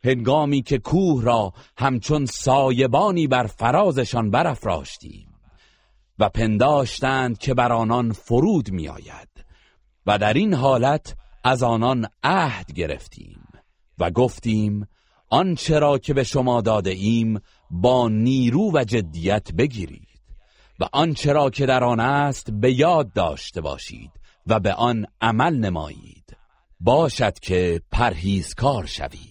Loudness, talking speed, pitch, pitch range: -21 LUFS, 120 wpm, 125 Hz, 110-135 Hz